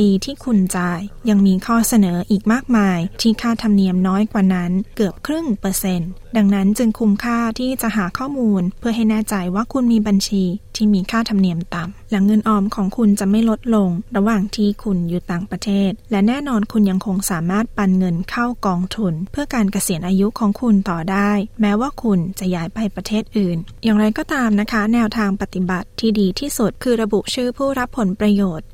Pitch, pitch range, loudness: 205 Hz, 190-225 Hz, -18 LUFS